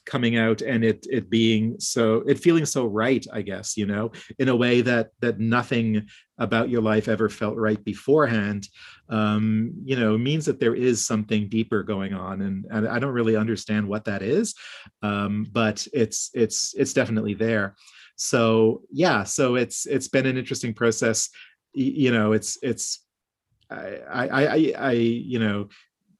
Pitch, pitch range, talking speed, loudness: 115 Hz, 105-125 Hz, 170 wpm, -23 LUFS